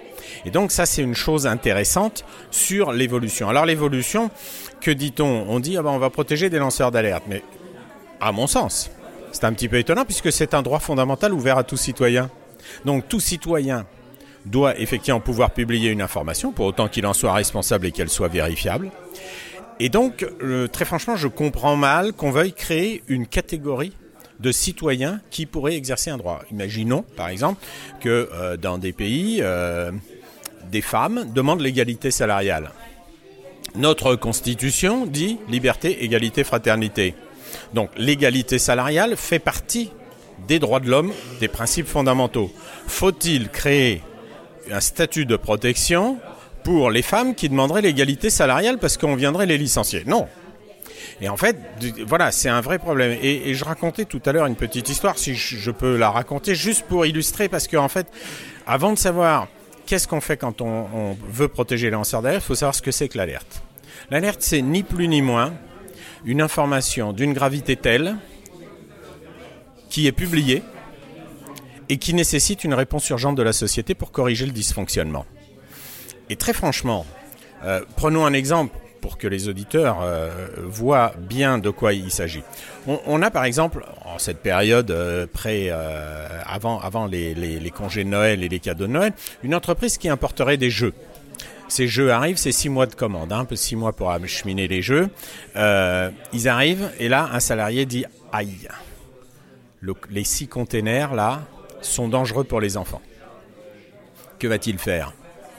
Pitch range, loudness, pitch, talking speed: 110-155 Hz, -21 LUFS, 130 Hz, 170 wpm